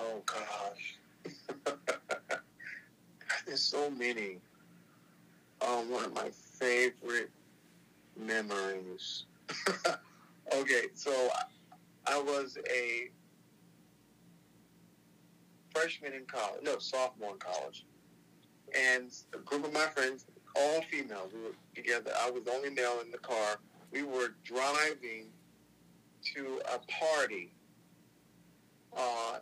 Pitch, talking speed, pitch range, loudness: 125 Hz, 100 wpm, 105-140 Hz, -35 LUFS